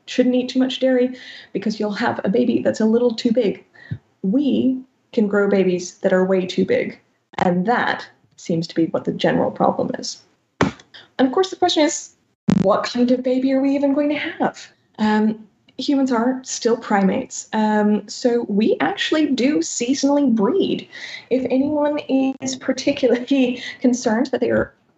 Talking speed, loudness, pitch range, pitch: 170 wpm, -20 LUFS, 215-270 Hz, 250 Hz